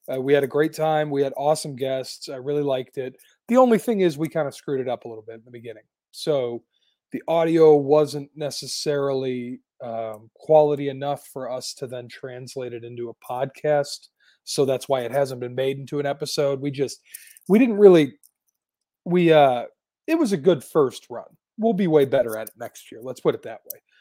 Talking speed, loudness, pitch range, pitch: 205 wpm, -22 LUFS, 130-155 Hz, 140 Hz